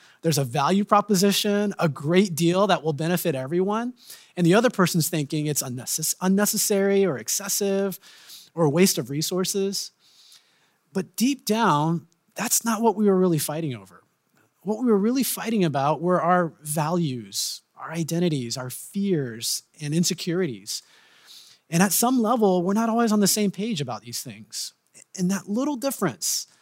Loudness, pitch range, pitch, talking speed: -23 LUFS, 155-205 Hz, 180 Hz, 155 wpm